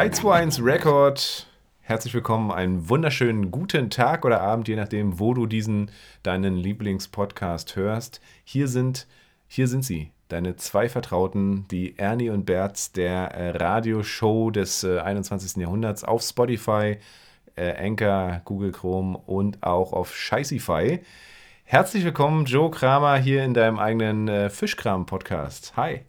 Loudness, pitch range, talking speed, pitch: -24 LUFS, 95-120 Hz, 135 wpm, 105 Hz